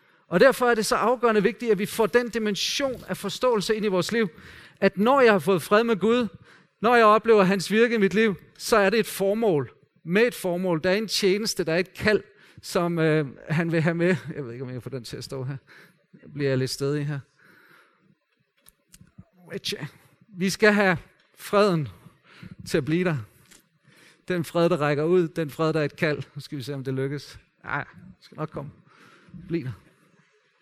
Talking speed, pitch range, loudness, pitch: 205 wpm, 150-210 Hz, -24 LUFS, 180 Hz